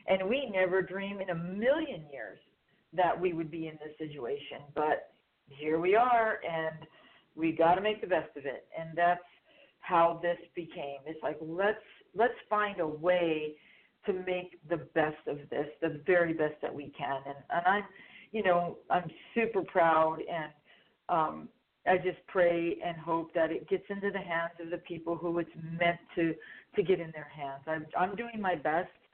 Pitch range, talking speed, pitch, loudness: 160-190 Hz, 185 wpm, 170 Hz, -32 LUFS